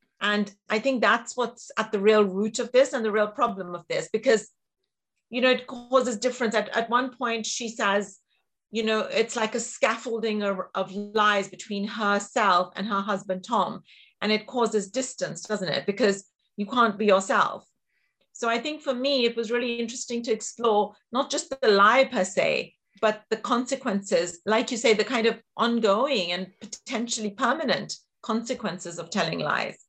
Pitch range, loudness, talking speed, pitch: 205-245 Hz, -25 LUFS, 180 wpm, 220 Hz